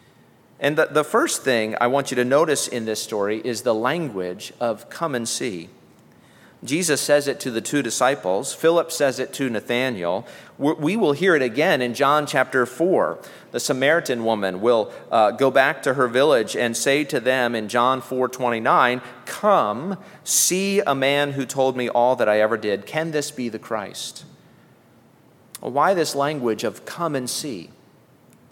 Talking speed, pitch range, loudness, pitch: 170 wpm, 120-145 Hz, -21 LUFS, 130 Hz